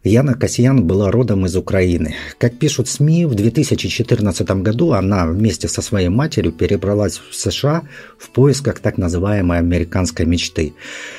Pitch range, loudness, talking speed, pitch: 90-120 Hz, -16 LUFS, 140 wpm, 105 Hz